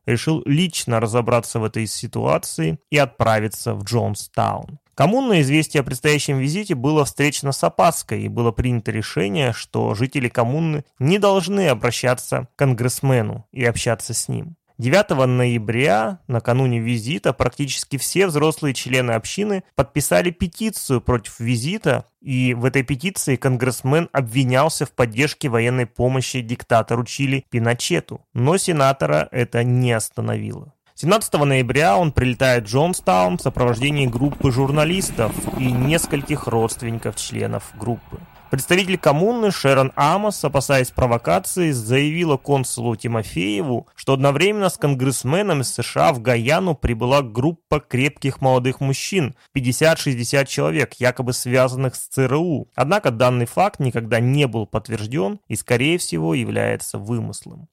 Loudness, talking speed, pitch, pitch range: -19 LUFS, 125 wpm, 130 Hz, 120-150 Hz